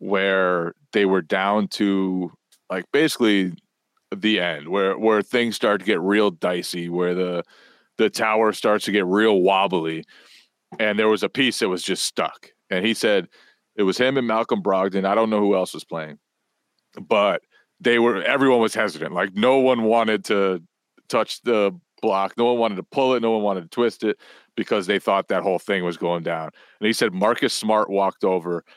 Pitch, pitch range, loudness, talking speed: 100 Hz, 95-115 Hz, -21 LUFS, 195 wpm